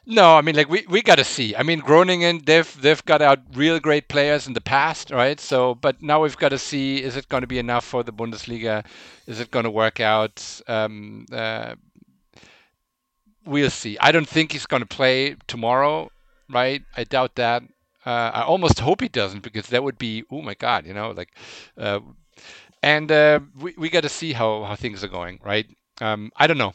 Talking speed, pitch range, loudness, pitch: 215 wpm, 115-150 Hz, -20 LUFS, 130 Hz